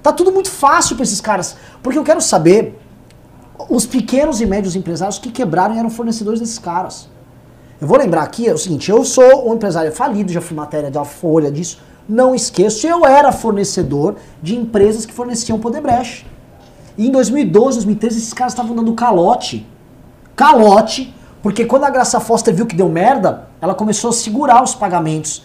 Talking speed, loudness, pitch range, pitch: 180 wpm, -14 LUFS, 175-245 Hz, 220 Hz